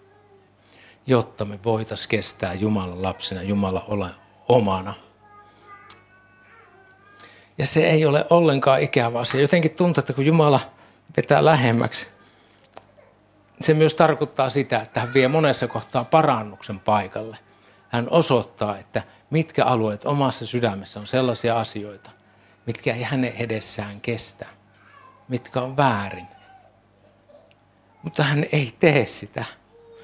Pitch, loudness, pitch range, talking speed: 120 Hz, -21 LUFS, 105-145 Hz, 115 wpm